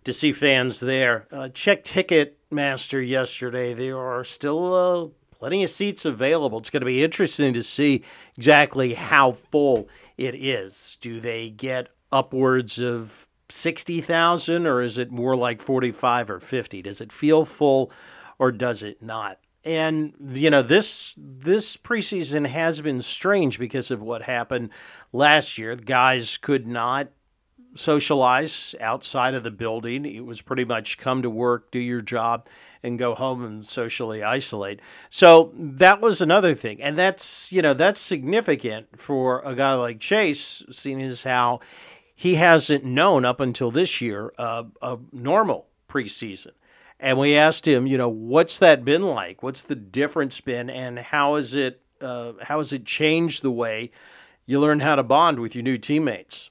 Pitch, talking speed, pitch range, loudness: 130 Hz, 165 wpm, 120-150 Hz, -21 LUFS